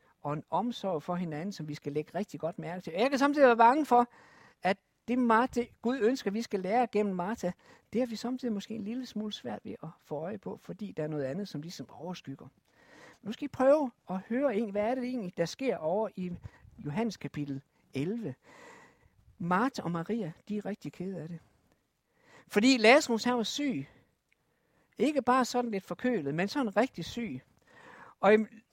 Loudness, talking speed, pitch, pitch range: -31 LUFS, 195 wpm, 210 Hz, 175-245 Hz